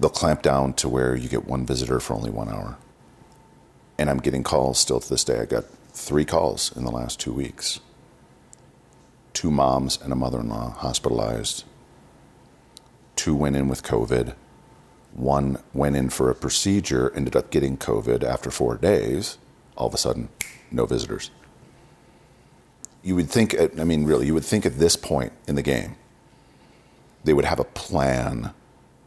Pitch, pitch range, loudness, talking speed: 65 Hz, 65-75 Hz, -23 LUFS, 170 wpm